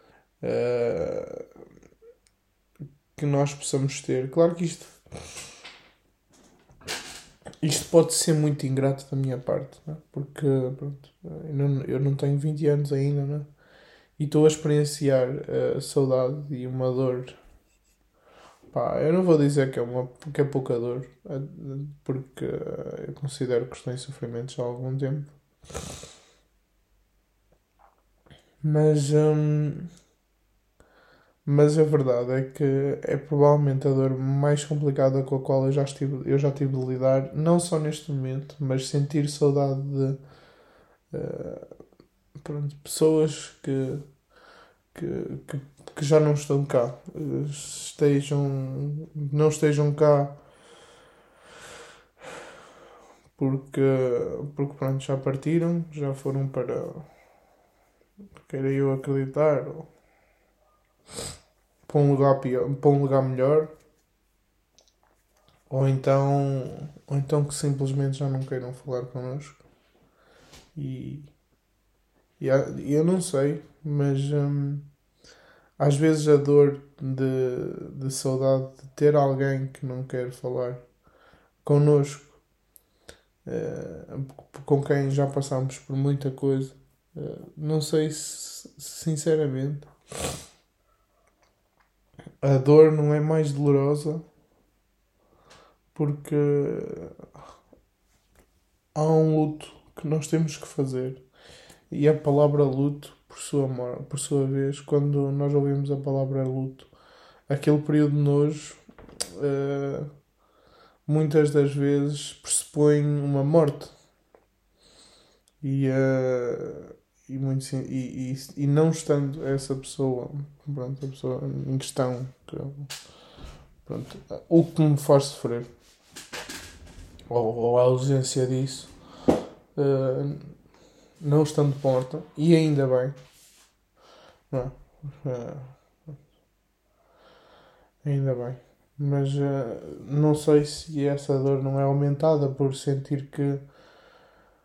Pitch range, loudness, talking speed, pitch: 135-150 Hz, -25 LUFS, 105 wpm, 140 Hz